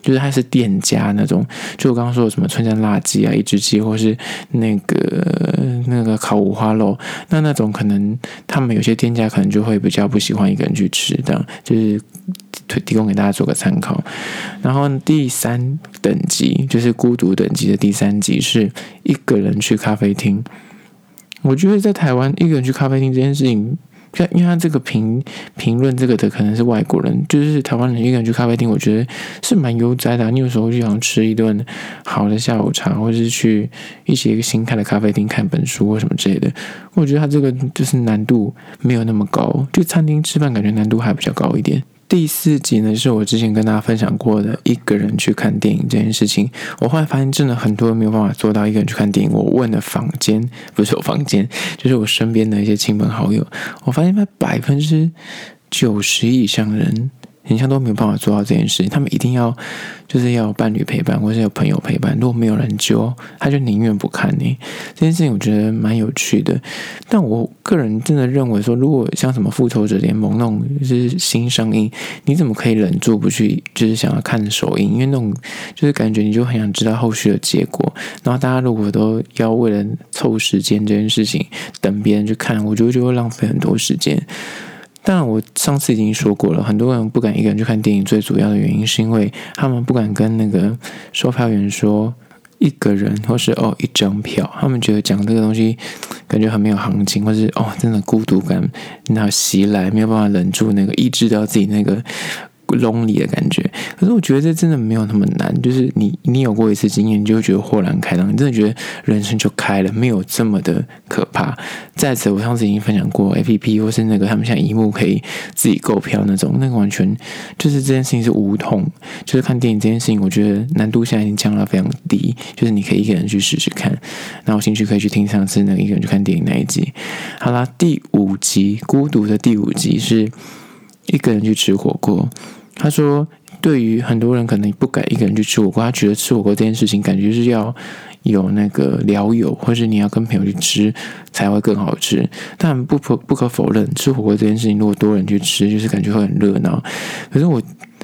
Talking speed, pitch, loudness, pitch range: 325 characters per minute, 115 Hz, -16 LUFS, 105-135 Hz